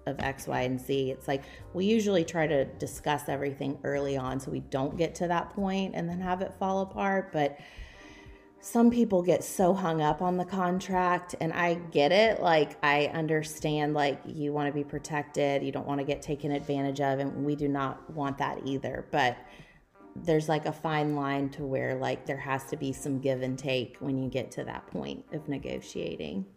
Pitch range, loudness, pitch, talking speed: 135-165 Hz, -30 LUFS, 145 Hz, 205 wpm